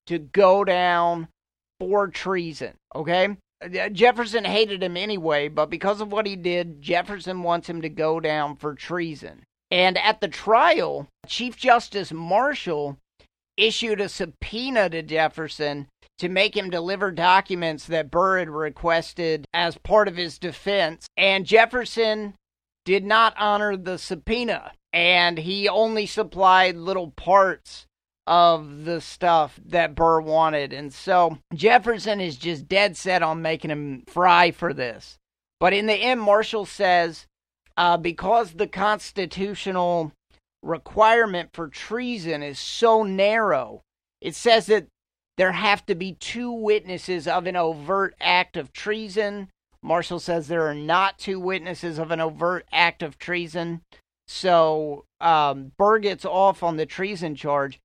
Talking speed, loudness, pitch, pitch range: 140 wpm, -22 LUFS, 180 Hz, 165-205 Hz